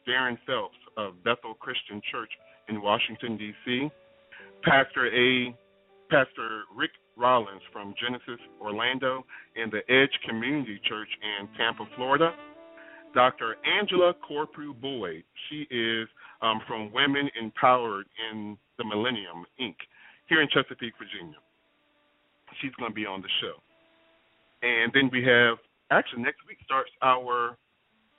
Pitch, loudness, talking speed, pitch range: 125 Hz, -27 LUFS, 125 wpm, 110-140 Hz